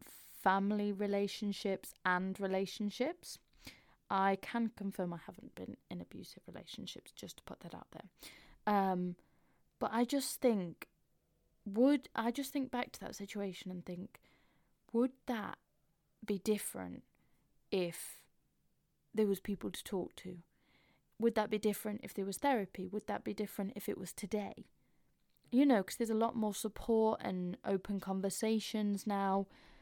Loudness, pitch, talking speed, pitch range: -37 LUFS, 205 Hz, 145 wpm, 195-220 Hz